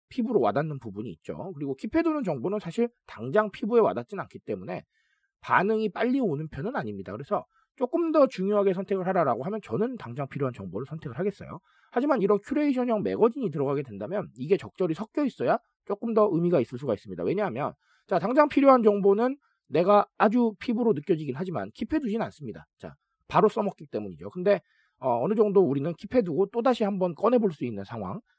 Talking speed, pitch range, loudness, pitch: 430 characters per minute, 165-240 Hz, -27 LUFS, 205 Hz